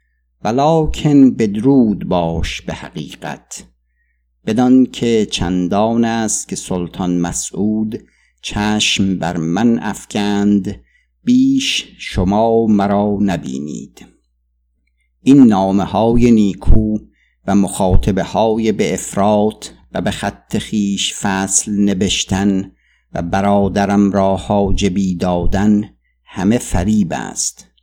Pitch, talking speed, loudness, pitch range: 100 Hz, 90 wpm, -15 LUFS, 90-110 Hz